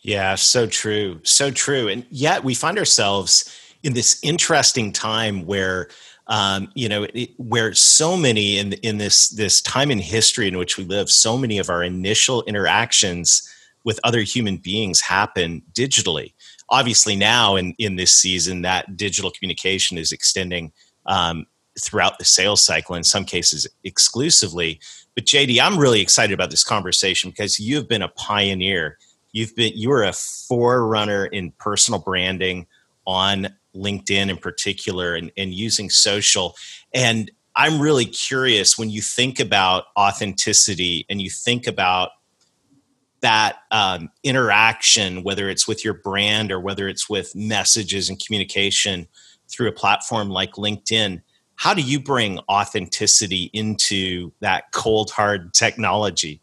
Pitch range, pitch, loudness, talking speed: 95-110 Hz, 100 Hz, -17 LUFS, 145 wpm